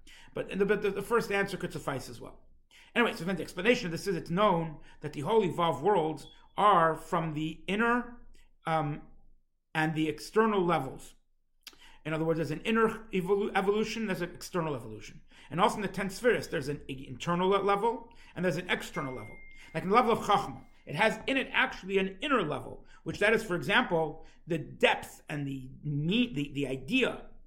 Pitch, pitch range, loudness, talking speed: 175 Hz, 155-205 Hz, -30 LUFS, 195 wpm